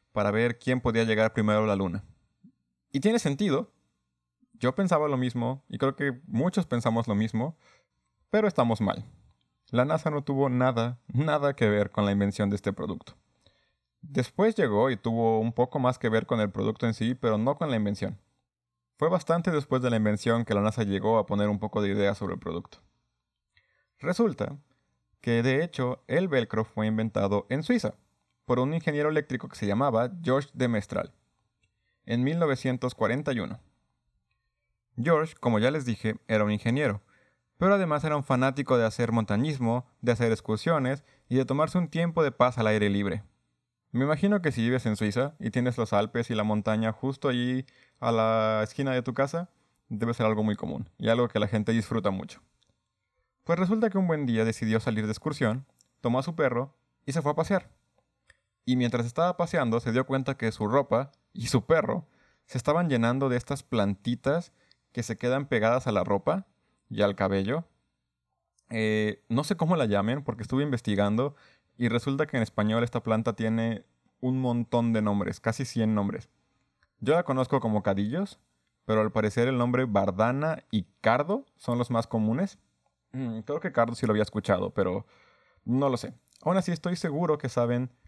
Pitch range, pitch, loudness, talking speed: 110-140 Hz, 120 Hz, -28 LUFS, 185 wpm